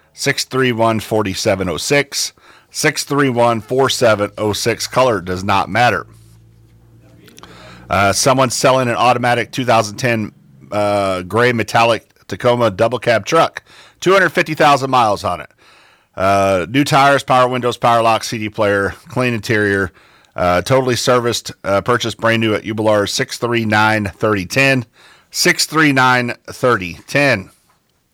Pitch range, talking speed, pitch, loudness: 105-130 Hz, 95 wpm, 115 Hz, -15 LUFS